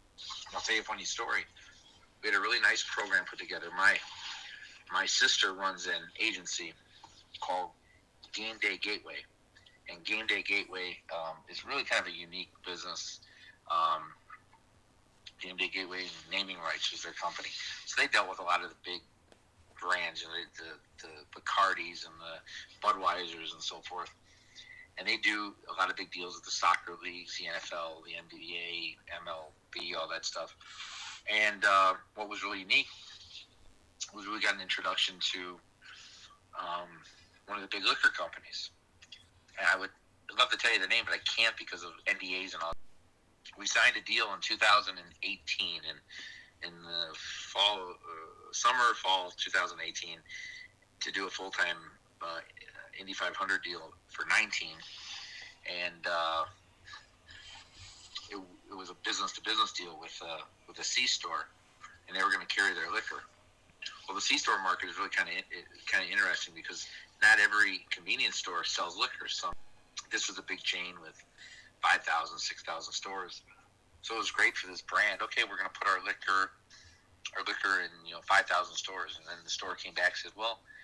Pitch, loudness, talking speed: 95 Hz, -32 LUFS, 170 wpm